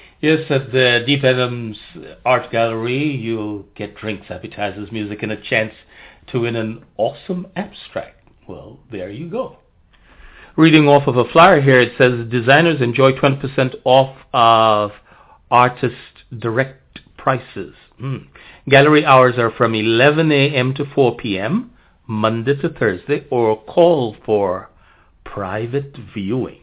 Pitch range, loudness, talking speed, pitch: 110-140 Hz, -16 LUFS, 130 wpm, 125 Hz